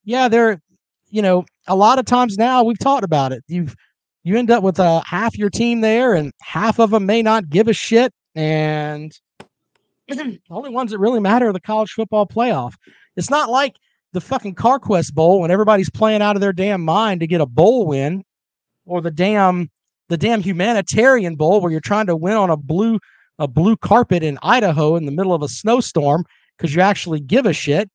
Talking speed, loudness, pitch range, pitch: 210 wpm, -16 LUFS, 170-225 Hz, 200 Hz